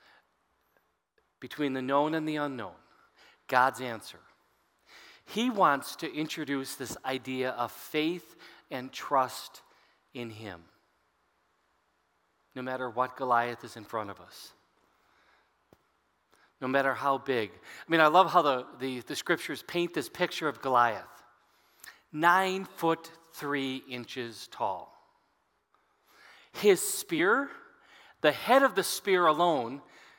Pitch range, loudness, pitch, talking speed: 125-175 Hz, -29 LUFS, 140 Hz, 120 wpm